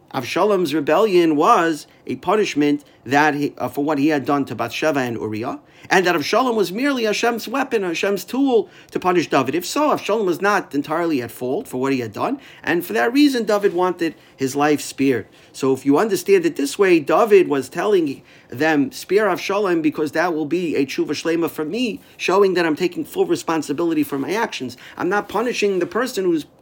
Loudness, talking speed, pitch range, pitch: -19 LUFS, 200 wpm, 145-245 Hz, 175 Hz